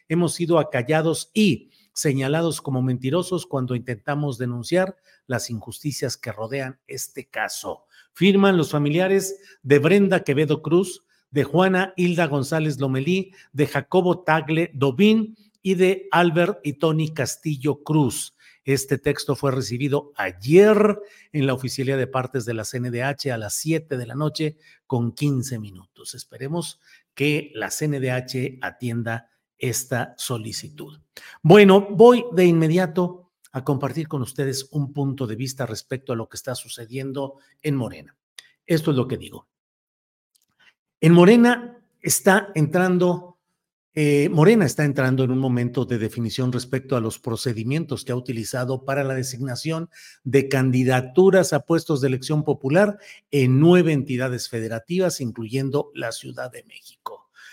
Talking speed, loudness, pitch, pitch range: 140 wpm, -21 LUFS, 145 Hz, 130-175 Hz